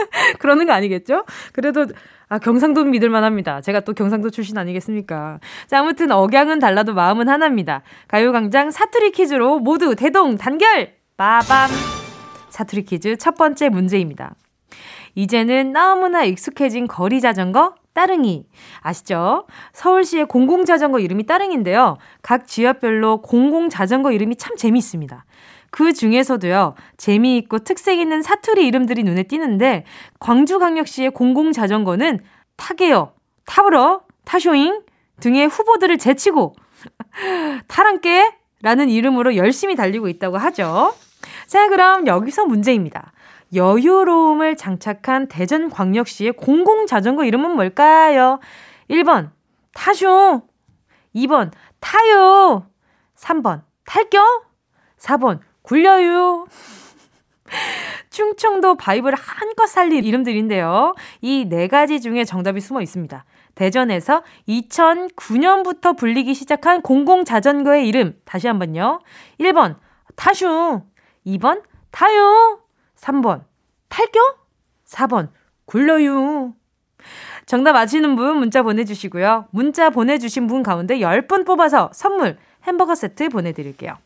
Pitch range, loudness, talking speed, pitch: 220-335 Hz, -16 LUFS, 270 characters per minute, 270 Hz